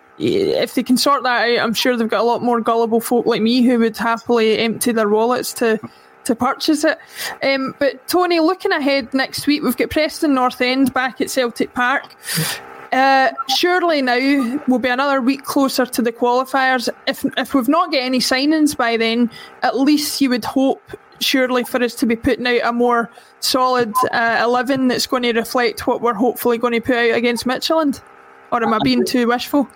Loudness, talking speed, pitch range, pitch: -17 LUFS, 200 wpm, 240-275 Hz, 255 Hz